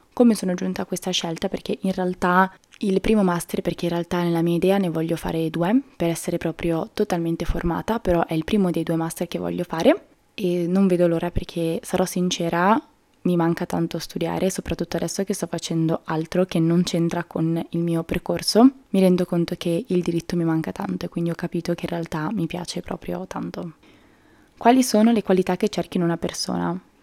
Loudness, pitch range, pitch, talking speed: -23 LUFS, 170-190 Hz, 175 Hz, 200 wpm